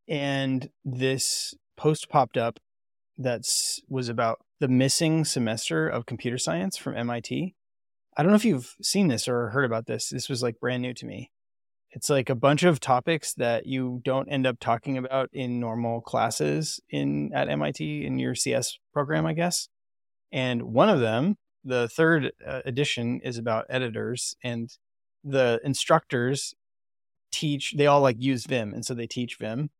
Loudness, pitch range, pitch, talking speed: -26 LUFS, 115-145 Hz, 130 Hz, 165 wpm